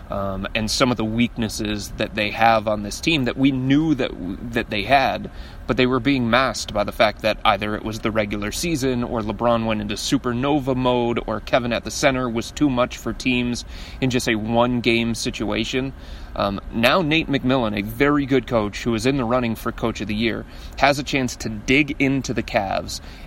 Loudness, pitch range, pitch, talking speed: -21 LUFS, 110-130 Hz, 120 Hz, 210 wpm